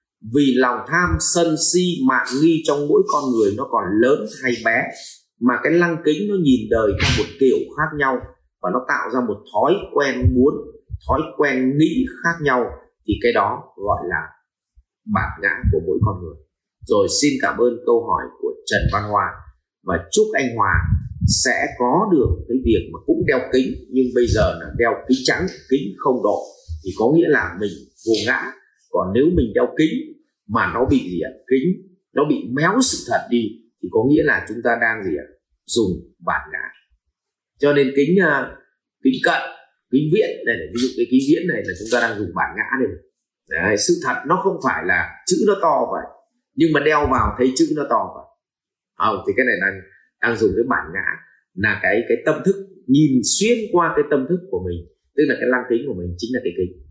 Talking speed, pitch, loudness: 210 wpm, 170 Hz, -19 LUFS